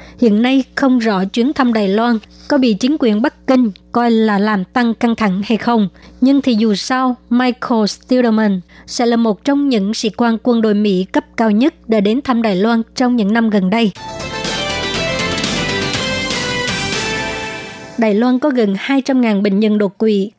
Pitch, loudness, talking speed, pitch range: 230 Hz, -15 LUFS, 175 wpm, 210-250 Hz